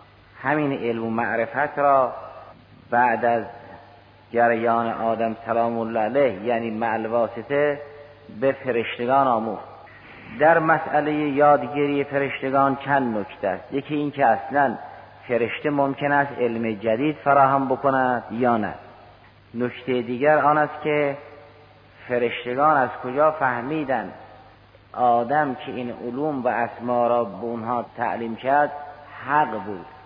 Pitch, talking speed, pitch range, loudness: 125 Hz, 120 wpm, 115-145 Hz, -22 LUFS